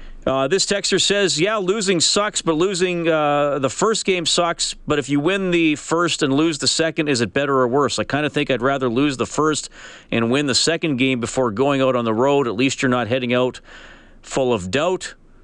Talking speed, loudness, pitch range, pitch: 225 wpm, -19 LUFS, 130-170 Hz, 145 Hz